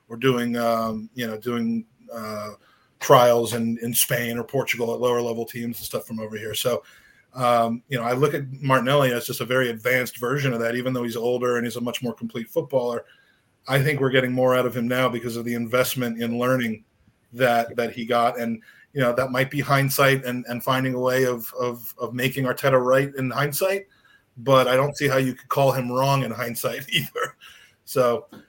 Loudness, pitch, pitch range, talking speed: -23 LUFS, 125 Hz, 115-130 Hz, 215 wpm